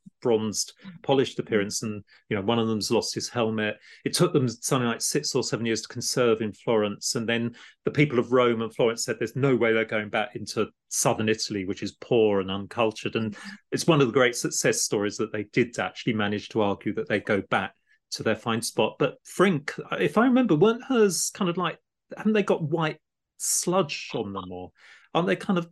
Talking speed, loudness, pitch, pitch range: 215 wpm, -26 LUFS, 115 Hz, 110-155 Hz